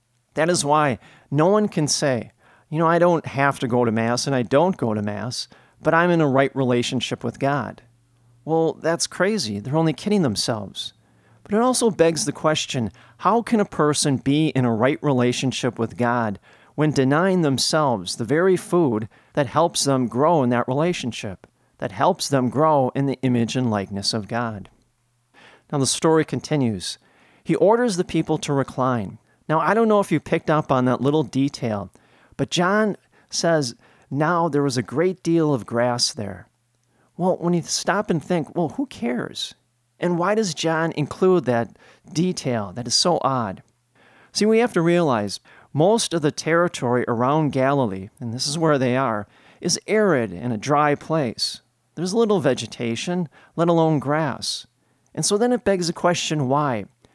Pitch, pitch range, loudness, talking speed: 145 Hz, 120-165 Hz, -21 LUFS, 175 wpm